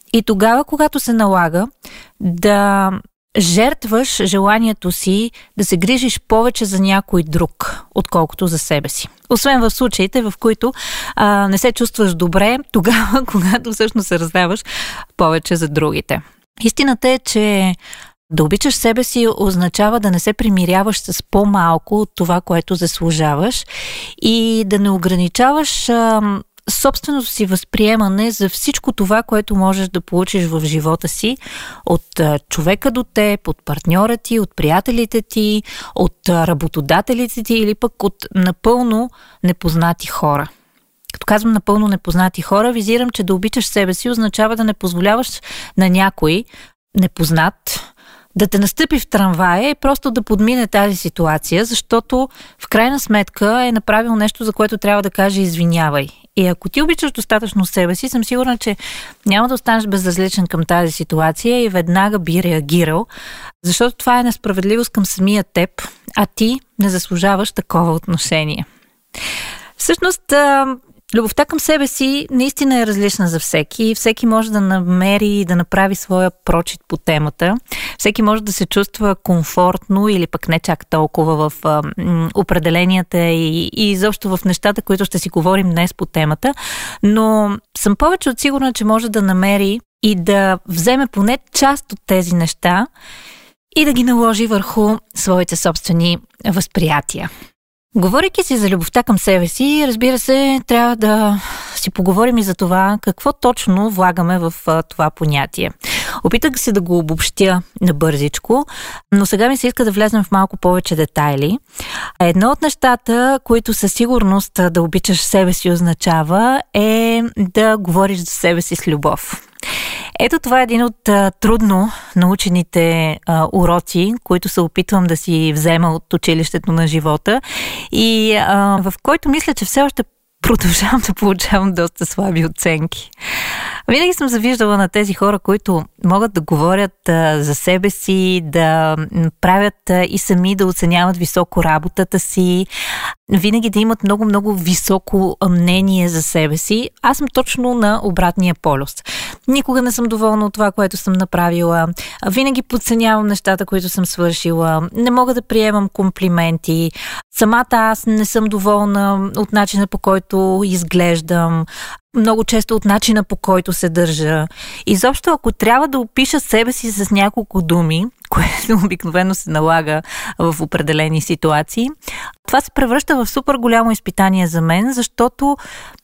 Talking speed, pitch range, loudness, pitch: 150 wpm, 175-230 Hz, -15 LUFS, 200 Hz